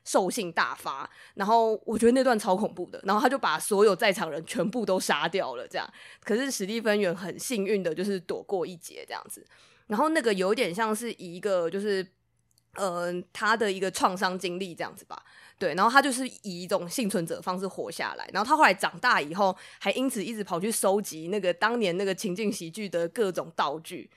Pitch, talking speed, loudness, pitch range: 200 Hz, 315 characters per minute, -27 LUFS, 185-225 Hz